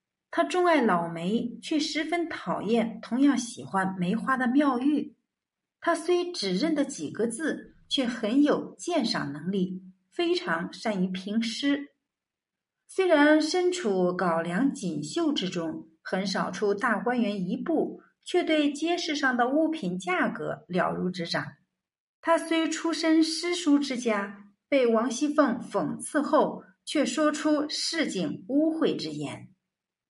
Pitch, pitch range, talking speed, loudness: 255 Hz, 200-310 Hz, 190 characters per minute, -27 LUFS